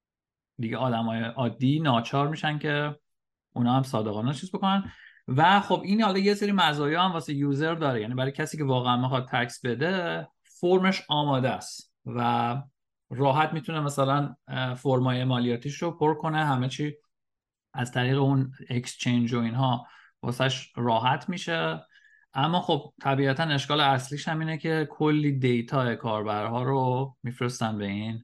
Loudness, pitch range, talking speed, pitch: -27 LUFS, 120-150 Hz, 145 wpm, 135 Hz